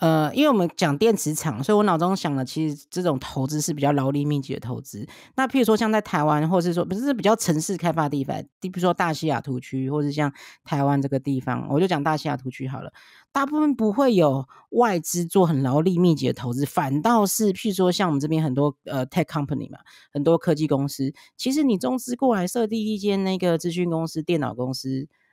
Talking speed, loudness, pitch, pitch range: 360 characters per minute, -23 LUFS, 160 Hz, 140-190 Hz